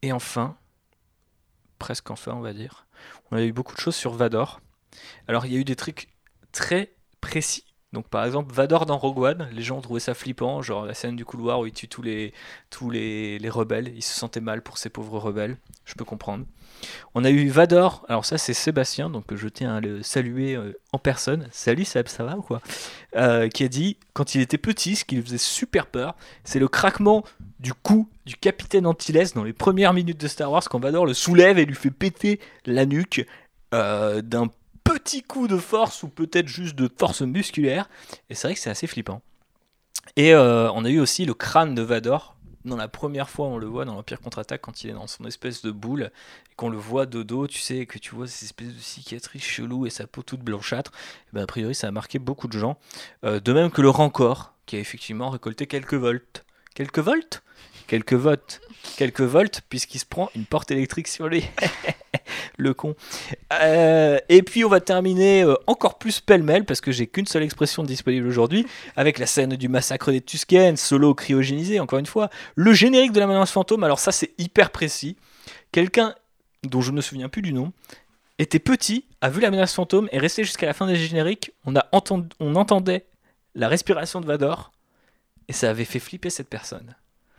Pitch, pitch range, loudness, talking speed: 135 Hz, 120-170 Hz, -22 LUFS, 210 wpm